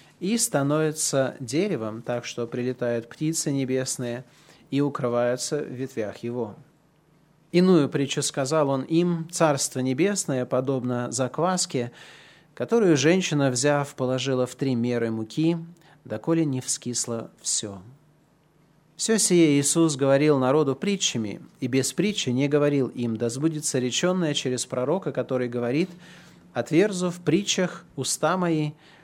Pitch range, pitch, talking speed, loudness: 125-160 Hz, 145 Hz, 120 wpm, -24 LUFS